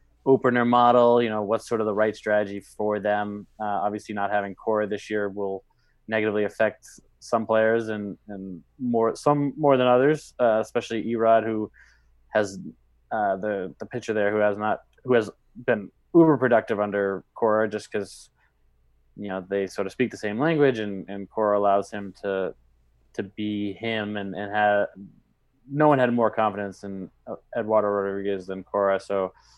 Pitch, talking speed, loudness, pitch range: 105 Hz, 175 wpm, -24 LUFS, 100-115 Hz